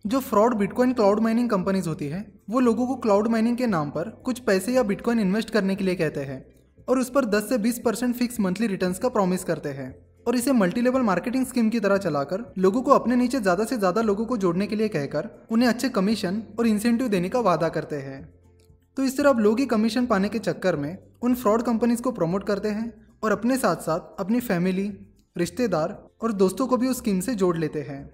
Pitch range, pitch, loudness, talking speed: 185-240 Hz, 210 Hz, -24 LUFS, 225 wpm